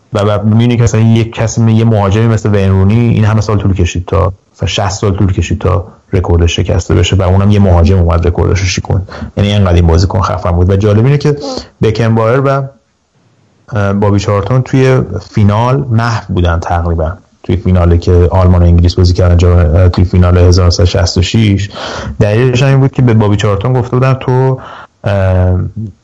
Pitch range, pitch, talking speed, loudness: 90-110 Hz, 100 Hz, 175 wpm, -10 LUFS